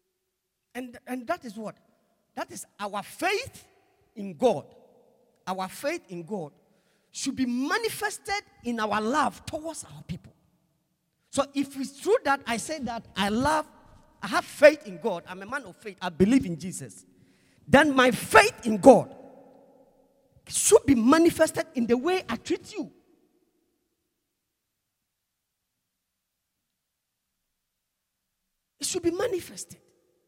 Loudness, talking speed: -25 LUFS, 130 wpm